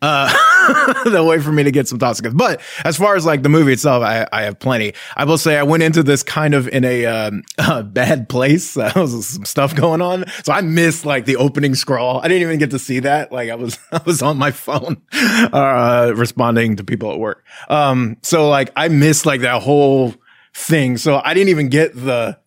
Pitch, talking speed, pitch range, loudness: 140 Hz, 225 wpm, 125-160 Hz, -15 LUFS